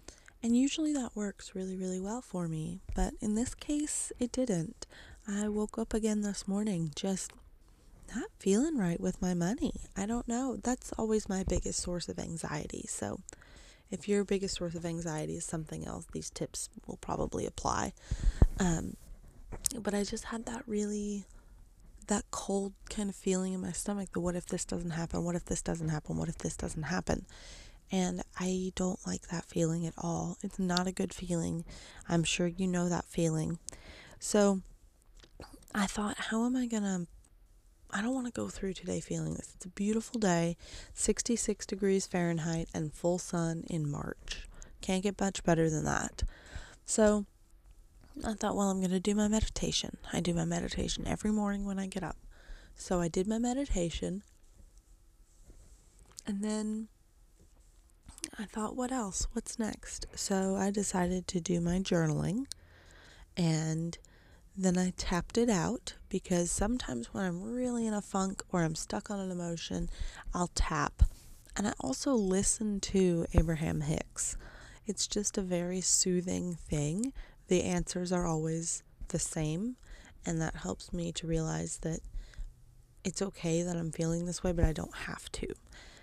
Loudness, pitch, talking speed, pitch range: -34 LUFS, 185 Hz, 165 wpm, 170-210 Hz